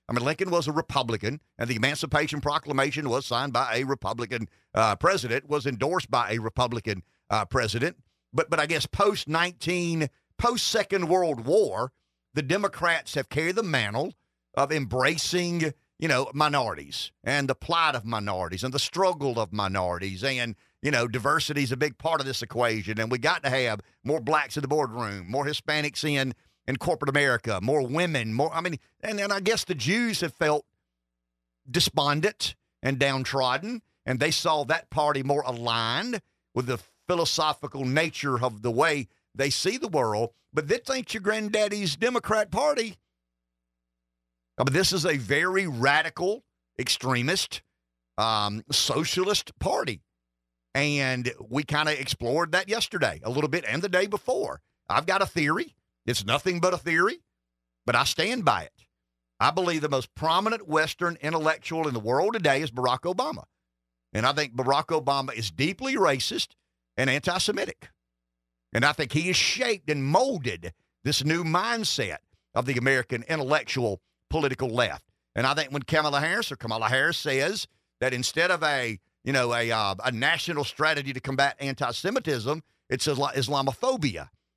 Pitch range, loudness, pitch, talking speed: 120-160 Hz, -26 LUFS, 140 Hz, 160 wpm